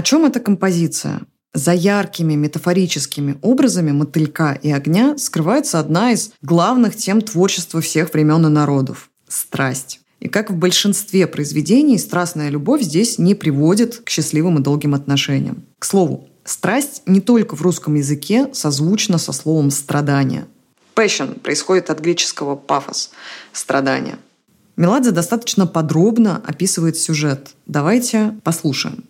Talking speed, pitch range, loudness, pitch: 130 wpm, 150-205 Hz, -16 LUFS, 170 Hz